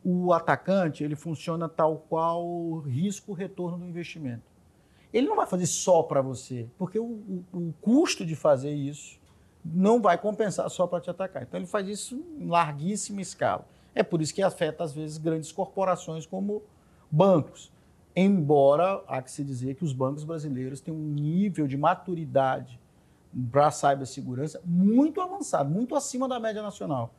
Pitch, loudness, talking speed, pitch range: 165 Hz, -27 LUFS, 160 wpm, 145-190 Hz